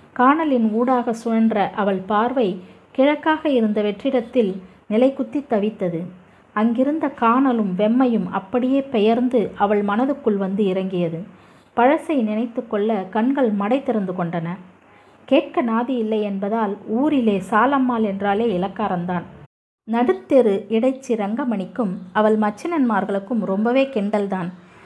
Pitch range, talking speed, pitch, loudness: 200-255 Hz, 100 wpm, 225 Hz, -20 LUFS